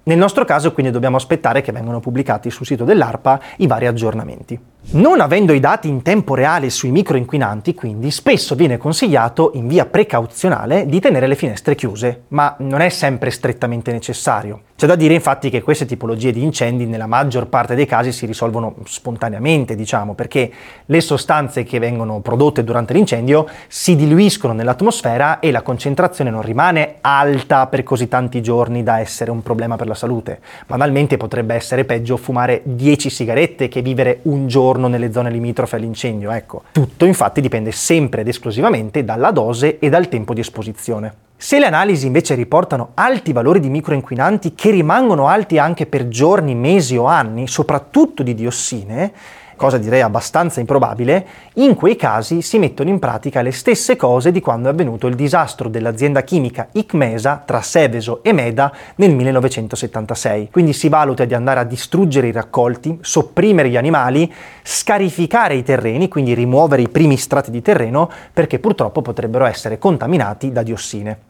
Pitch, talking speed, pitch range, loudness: 130 Hz, 165 wpm, 120-155 Hz, -15 LUFS